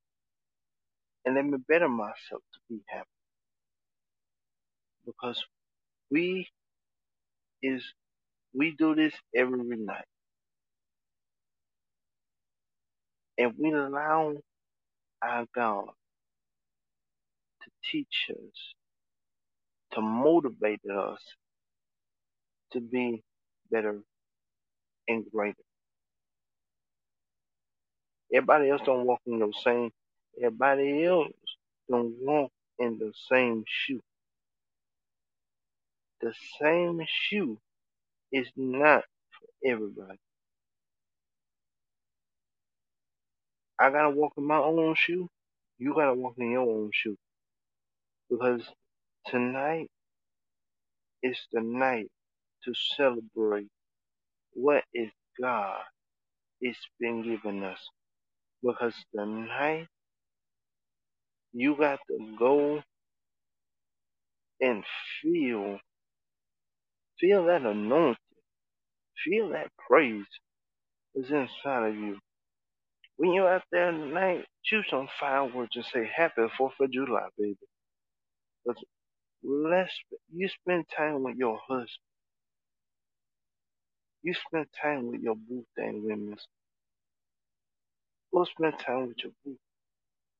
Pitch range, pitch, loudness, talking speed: 105-145 Hz, 120 Hz, -29 LUFS, 90 wpm